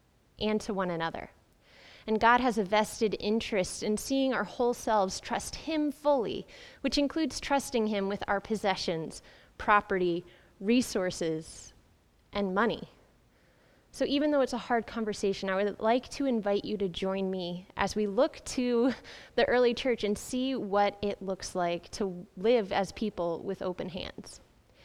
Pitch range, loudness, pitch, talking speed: 190-245 Hz, -30 LUFS, 210 Hz, 155 wpm